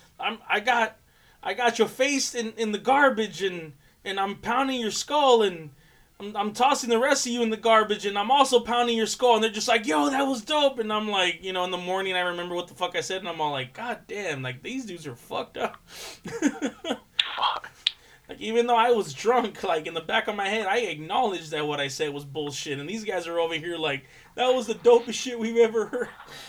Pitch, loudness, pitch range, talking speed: 210 Hz, -25 LUFS, 170-235 Hz, 240 wpm